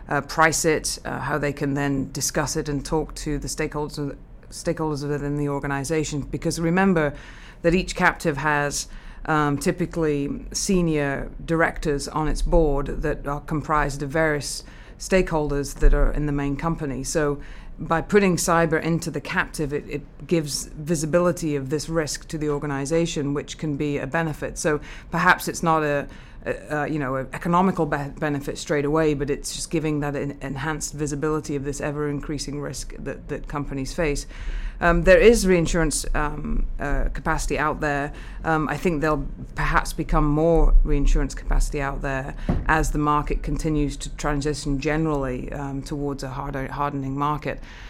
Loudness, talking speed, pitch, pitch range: -24 LUFS, 165 wpm, 150 Hz, 140-160 Hz